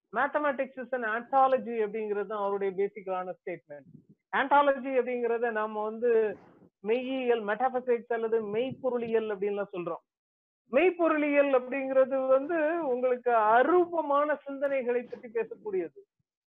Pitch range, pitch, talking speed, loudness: 215-275 Hz, 245 Hz, 95 wpm, -29 LUFS